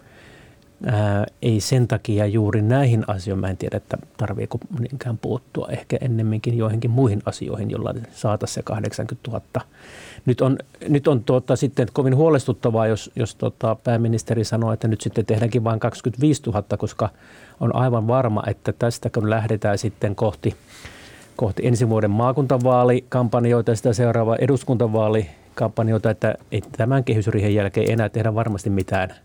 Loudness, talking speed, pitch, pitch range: -21 LUFS, 145 wpm, 115 Hz, 110-125 Hz